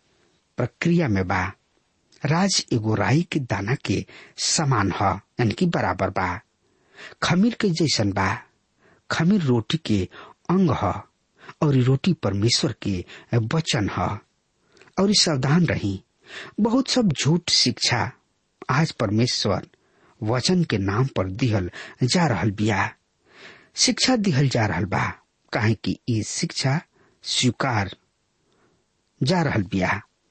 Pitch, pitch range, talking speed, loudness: 125 Hz, 100-165 Hz, 105 wpm, -22 LUFS